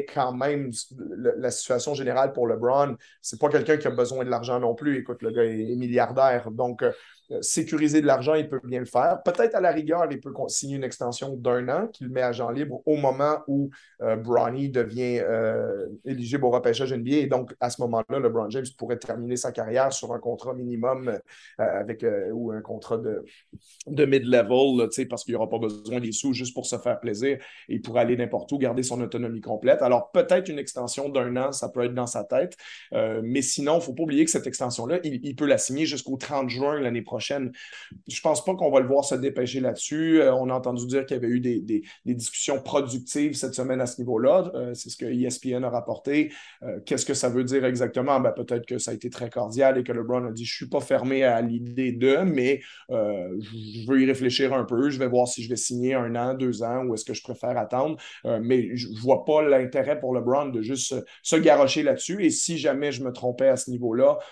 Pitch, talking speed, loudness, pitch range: 130 Hz, 235 wpm, -25 LUFS, 120-140 Hz